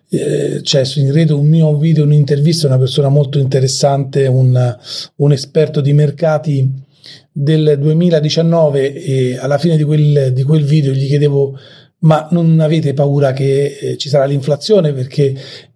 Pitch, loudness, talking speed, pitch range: 145 Hz, -13 LUFS, 150 wpm, 135-155 Hz